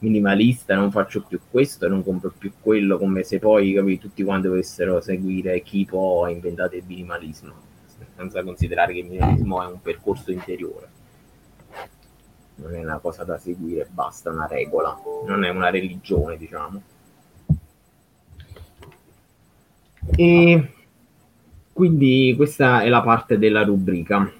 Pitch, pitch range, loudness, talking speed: 95 Hz, 90-115 Hz, -20 LUFS, 130 wpm